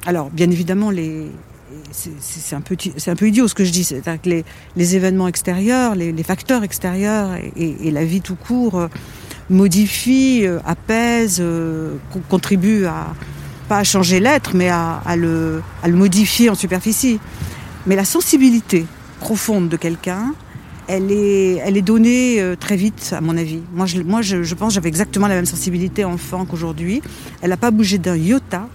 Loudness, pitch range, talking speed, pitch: -17 LUFS, 170-210 Hz, 185 wpm, 185 Hz